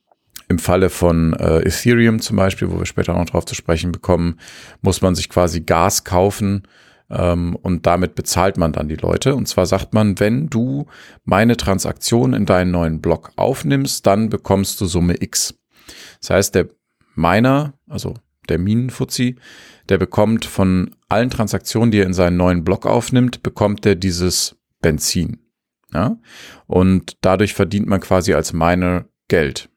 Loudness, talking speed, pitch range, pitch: -17 LUFS, 160 wpm, 90-110 Hz, 95 Hz